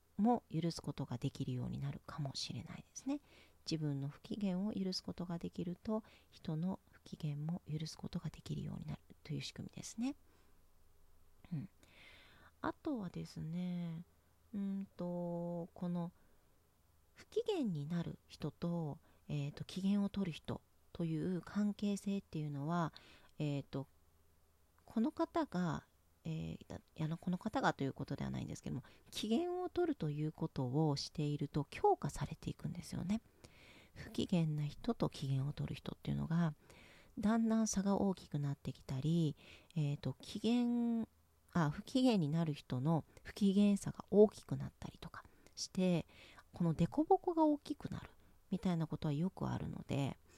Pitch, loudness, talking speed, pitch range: 165 Hz, -40 LUFS, 310 characters per minute, 140-200 Hz